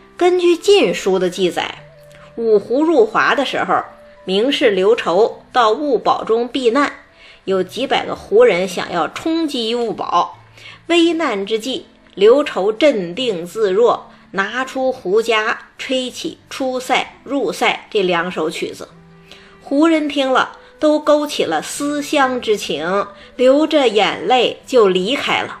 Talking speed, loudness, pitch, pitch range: 190 characters per minute, -16 LUFS, 260 Hz, 210-330 Hz